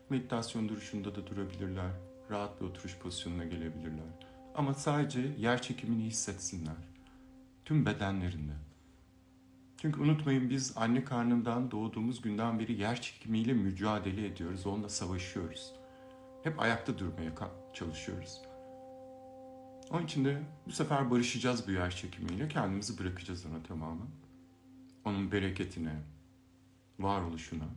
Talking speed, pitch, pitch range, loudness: 110 wpm, 105 Hz, 90-130 Hz, -36 LUFS